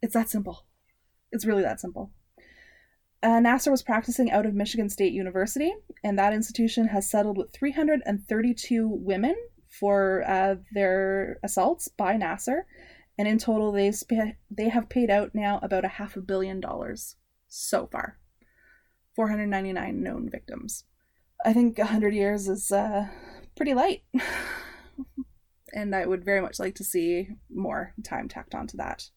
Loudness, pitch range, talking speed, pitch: -27 LUFS, 195-240 Hz, 150 wpm, 210 Hz